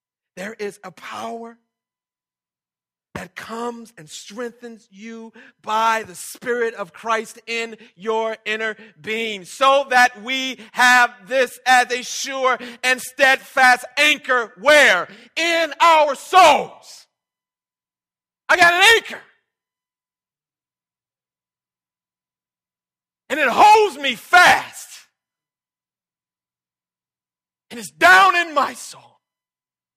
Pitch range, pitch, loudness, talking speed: 215-270 Hz, 235 Hz, -16 LUFS, 95 wpm